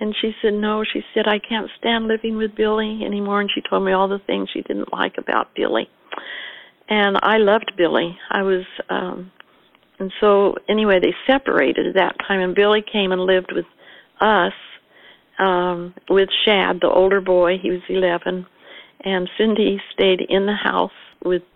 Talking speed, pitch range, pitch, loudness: 175 wpm, 185-215 Hz, 200 Hz, -19 LUFS